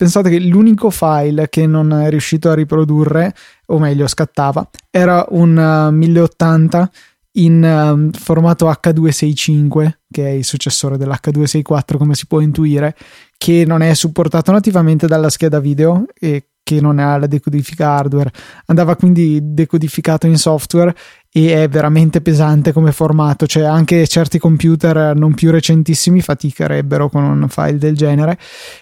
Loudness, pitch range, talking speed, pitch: -12 LUFS, 150-165 Hz, 140 wpm, 155 Hz